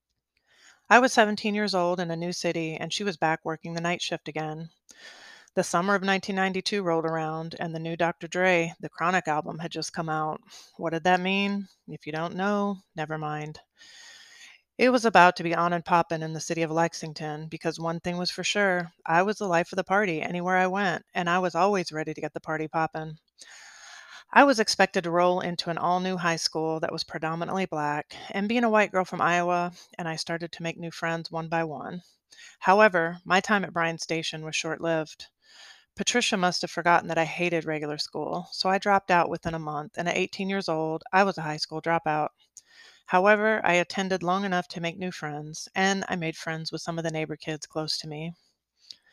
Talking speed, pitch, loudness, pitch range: 215 wpm, 170 Hz, -26 LUFS, 160-190 Hz